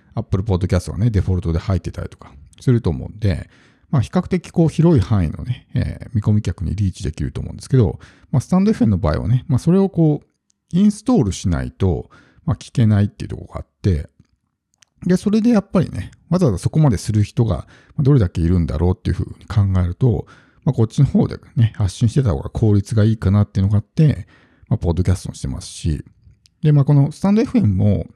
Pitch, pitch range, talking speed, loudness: 105 Hz, 95-140 Hz, 420 characters per minute, -18 LUFS